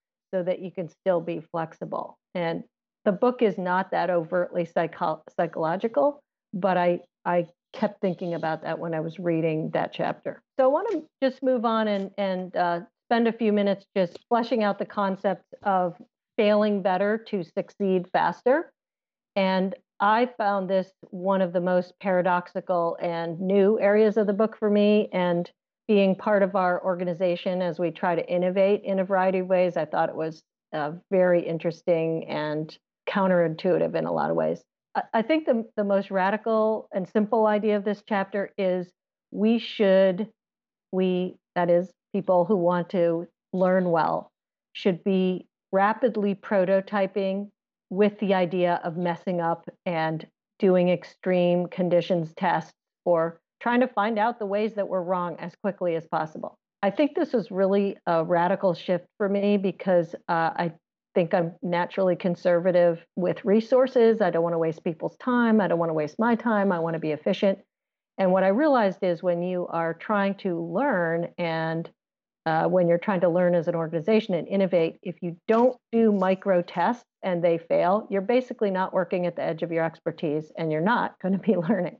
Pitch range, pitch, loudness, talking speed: 175-210 Hz, 185 Hz, -25 LUFS, 175 wpm